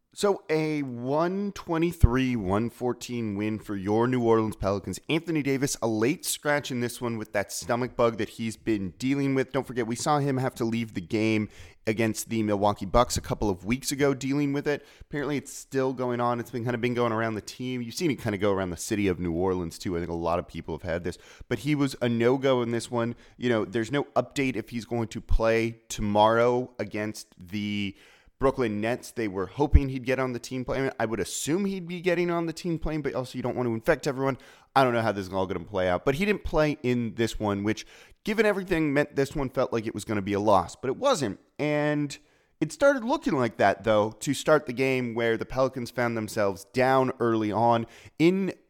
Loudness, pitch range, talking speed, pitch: -27 LUFS, 110-140 Hz, 240 wpm, 120 Hz